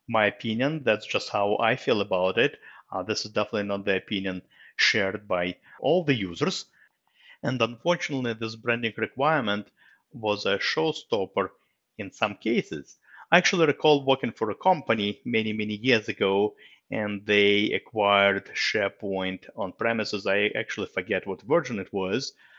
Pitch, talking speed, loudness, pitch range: 105 Hz, 150 wpm, -26 LUFS, 100-120 Hz